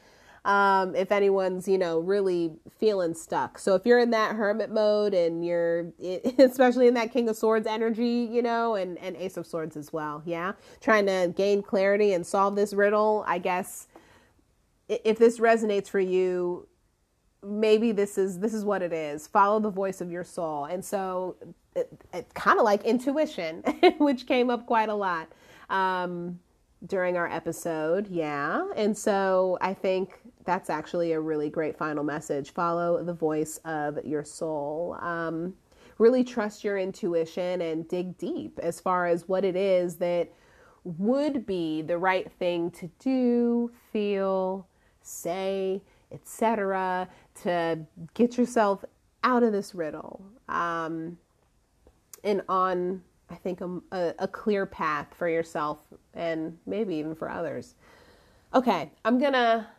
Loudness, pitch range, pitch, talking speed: -27 LUFS, 170-210 Hz, 185 Hz, 155 wpm